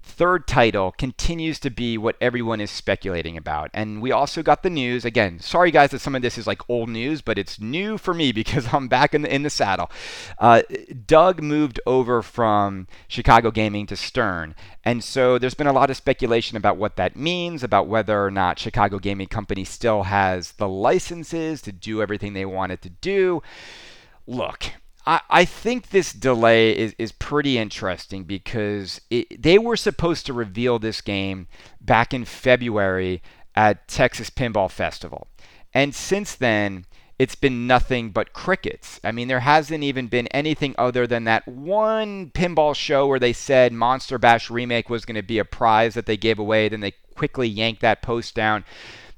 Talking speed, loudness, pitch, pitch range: 180 wpm, -21 LUFS, 120 Hz, 105-140 Hz